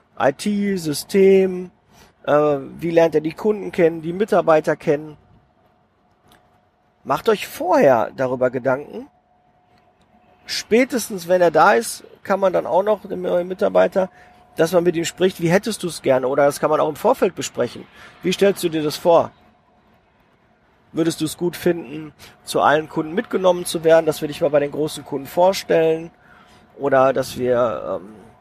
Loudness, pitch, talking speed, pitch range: -19 LUFS, 165 Hz, 165 wpm, 150-190 Hz